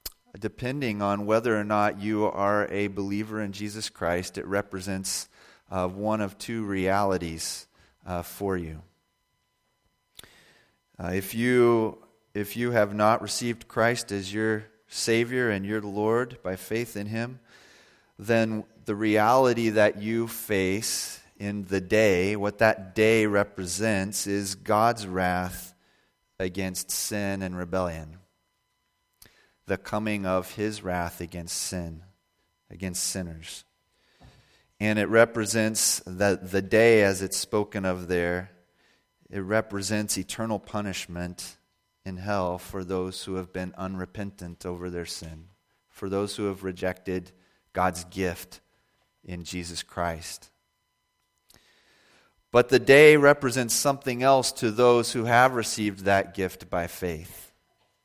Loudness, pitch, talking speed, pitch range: -26 LUFS, 100 Hz, 125 wpm, 90-110 Hz